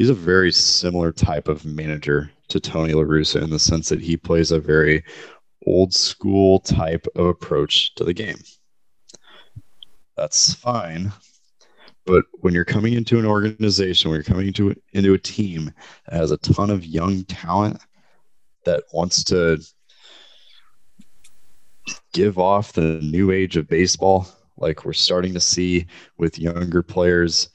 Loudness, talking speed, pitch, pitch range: -19 LUFS, 145 wpm, 90 Hz, 80-95 Hz